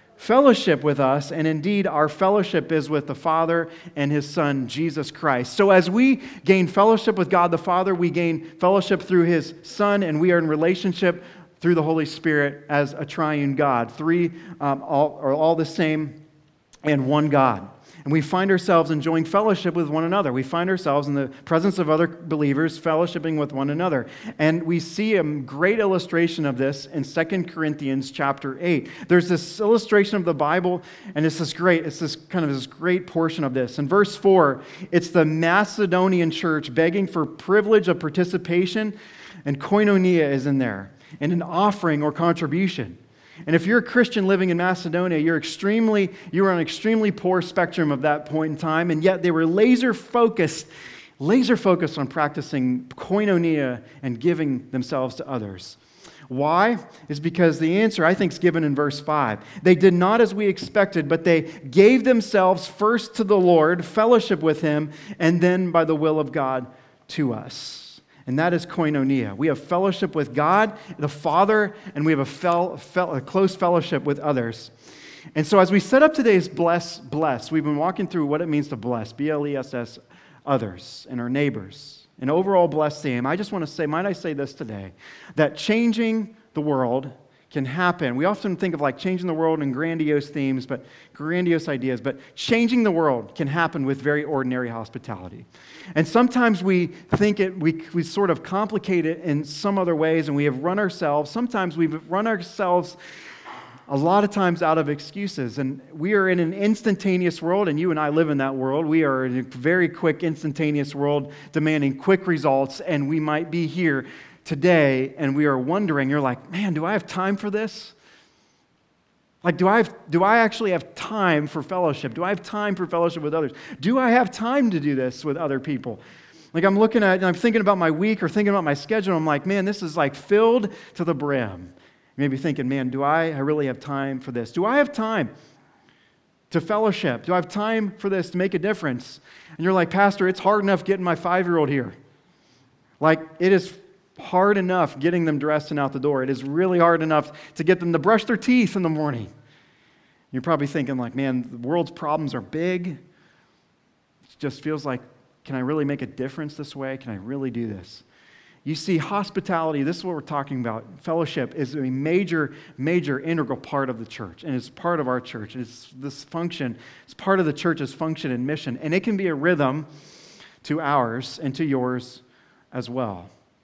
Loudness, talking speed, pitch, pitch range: -22 LUFS, 200 wpm, 160 Hz, 145-185 Hz